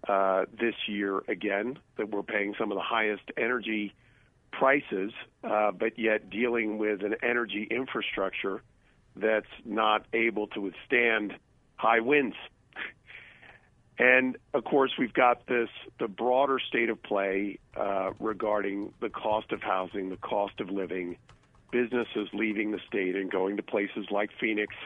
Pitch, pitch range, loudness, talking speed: 110 Hz, 100-120 Hz, -29 LUFS, 140 wpm